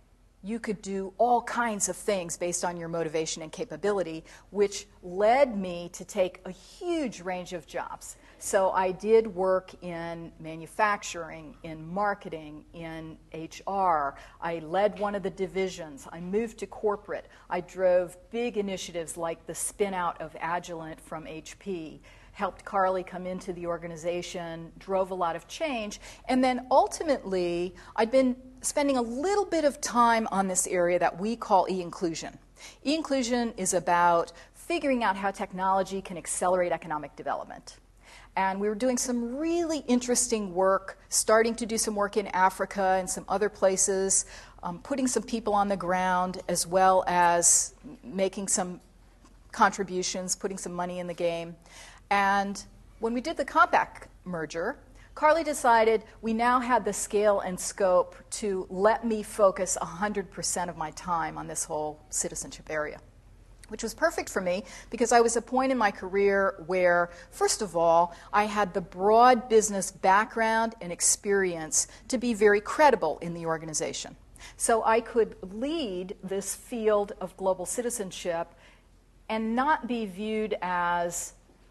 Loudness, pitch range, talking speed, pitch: -27 LUFS, 175-225 Hz, 155 wpm, 190 Hz